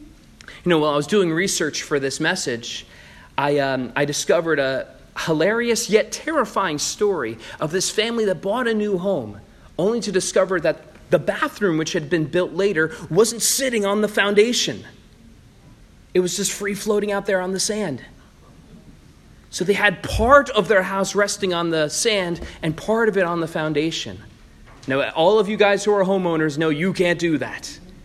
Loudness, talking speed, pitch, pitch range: -20 LUFS, 180 wpm, 185 Hz, 150-205 Hz